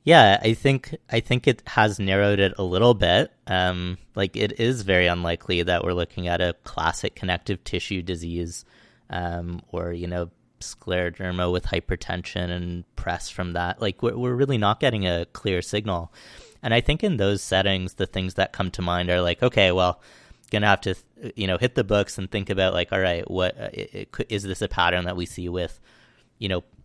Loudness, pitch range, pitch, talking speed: -24 LUFS, 90-105 Hz, 95 Hz, 205 wpm